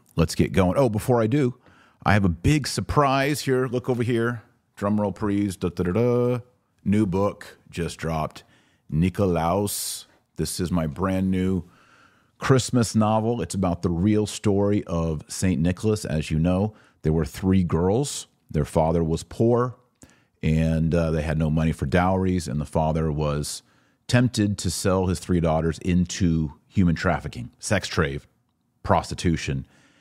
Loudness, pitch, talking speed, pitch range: -24 LUFS, 95 Hz, 155 wpm, 80-115 Hz